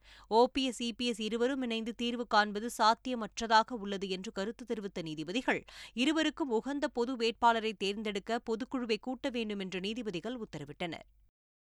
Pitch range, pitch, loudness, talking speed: 205-245 Hz, 230 Hz, -33 LUFS, 120 wpm